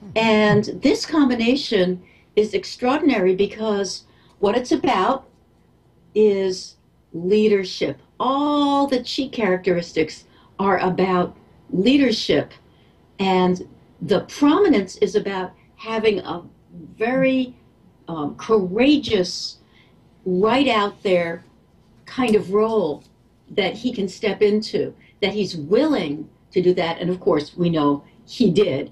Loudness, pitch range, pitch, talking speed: -20 LUFS, 185-245 Hz, 205 Hz, 110 wpm